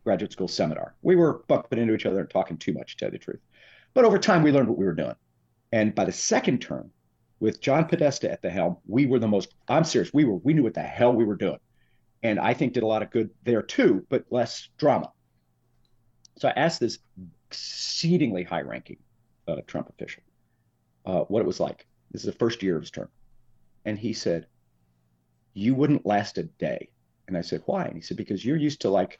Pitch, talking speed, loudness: 110 Hz, 225 wpm, -25 LUFS